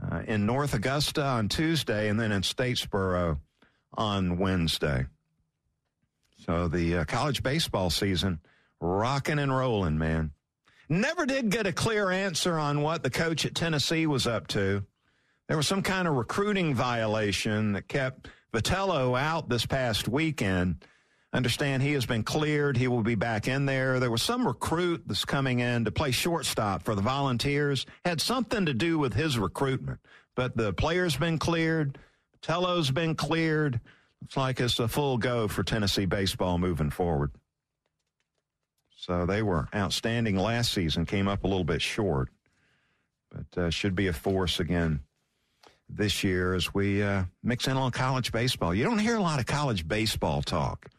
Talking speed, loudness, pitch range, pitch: 165 wpm, -28 LUFS, 100-145 Hz, 120 Hz